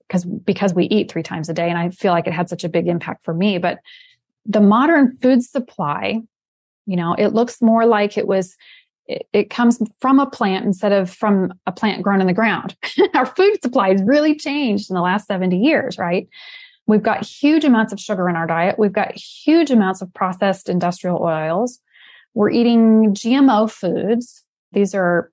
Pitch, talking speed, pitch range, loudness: 210 Hz, 195 wpm, 185-245 Hz, -17 LUFS